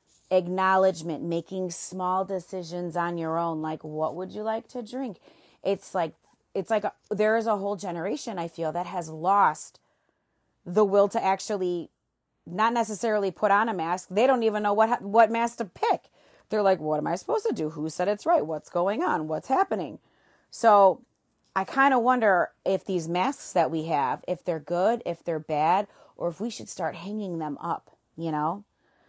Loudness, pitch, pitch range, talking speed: -26 LUFS, 190 Hz, 170-215 Hz, 190 wpm